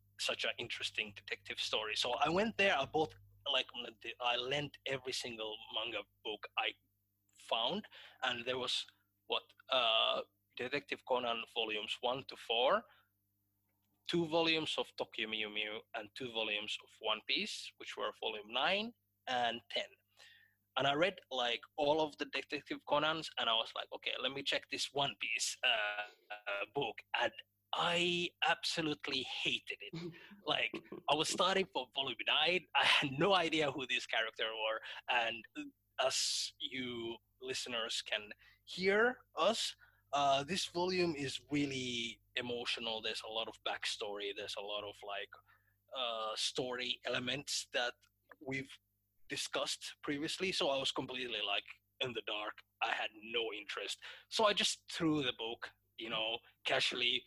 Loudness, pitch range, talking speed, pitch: -37 LUFS, 105-150 Hz, 150 wpm, 125 Hz